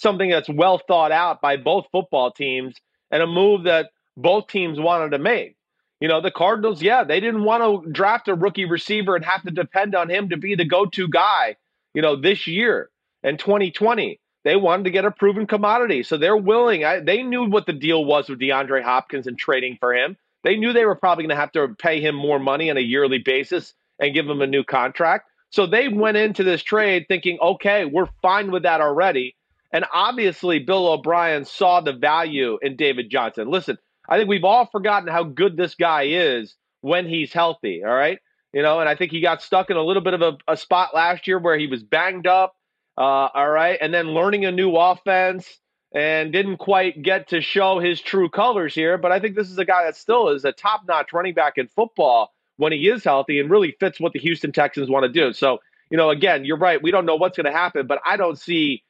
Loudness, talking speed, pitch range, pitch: -19 LUFS, 230 wpm, 155-200 Hz, 180 Hz